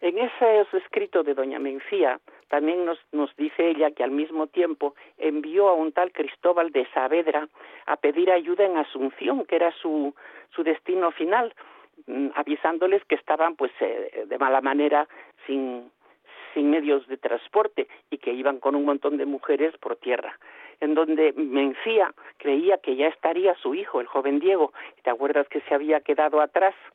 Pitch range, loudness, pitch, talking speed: 145-190 Hz, -24 LUFS, 155 Hz, 165 wpm